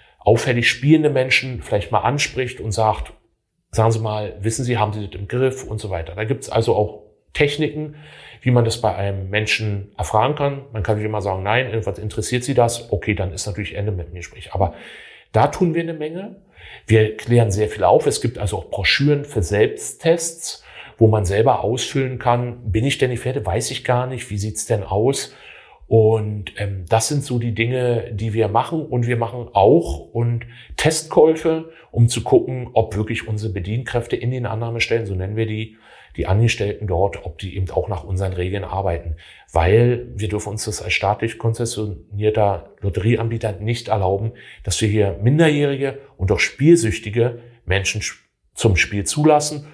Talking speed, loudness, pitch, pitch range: 185 wpm, -20 LUFS, 110 Hz, 105-125 Hz